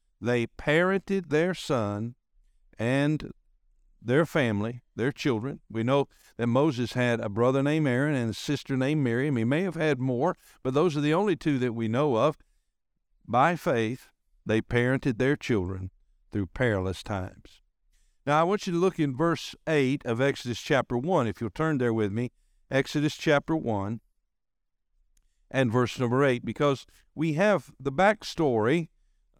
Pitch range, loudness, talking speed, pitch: 115-150 Hz, -27 LUFS, 160 wpm, 130 Hz